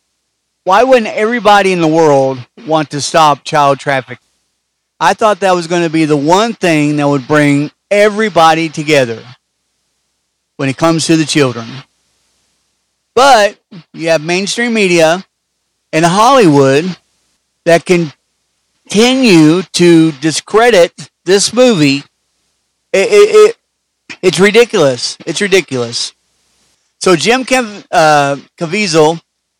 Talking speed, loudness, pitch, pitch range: 120 wpm, -10 LUFS, 165 Hz, 145-200 Hz